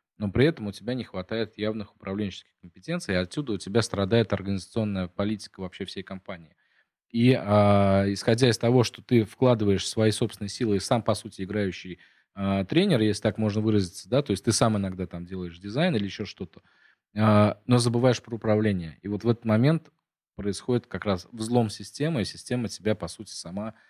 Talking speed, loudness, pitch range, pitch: 190 wpm, -26 LUFS, 100-120 Hz, 105 Hz